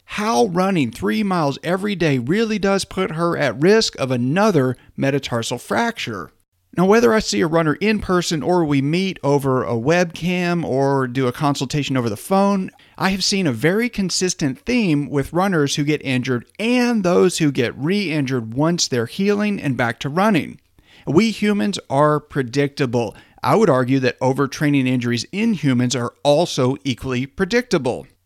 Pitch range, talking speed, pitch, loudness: 130-190 Hz, 165 wpm, 150 Hz, -19 LUFS